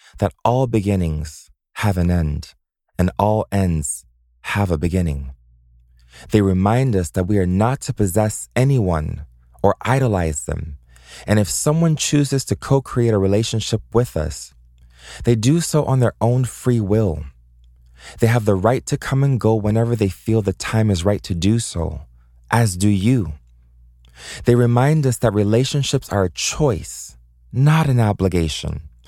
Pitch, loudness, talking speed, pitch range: 100 Hz, -19 LUFS, 155 wpm, 75-115 Hz